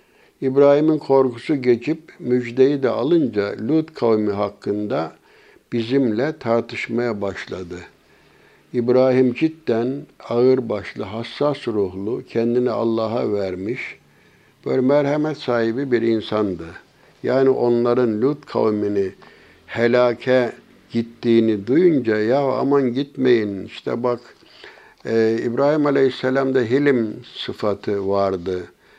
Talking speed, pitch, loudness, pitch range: 85 wpm, 120 Hz, -20 LUFS, 110-135 Hz